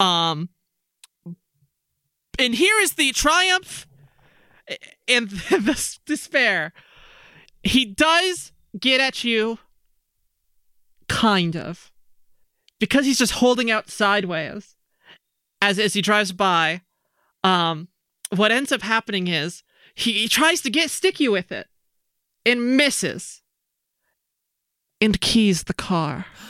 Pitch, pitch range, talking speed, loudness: 210 Hz, 175-260 Hz, 105 wpm, -20 LUFS